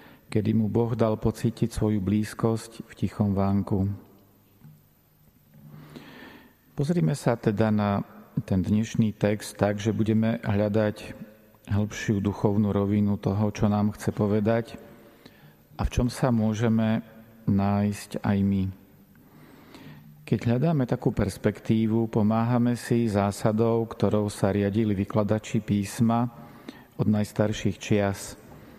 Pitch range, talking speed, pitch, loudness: 100-115 Hz, 110 wpm, 110 Hz, -26 LUFS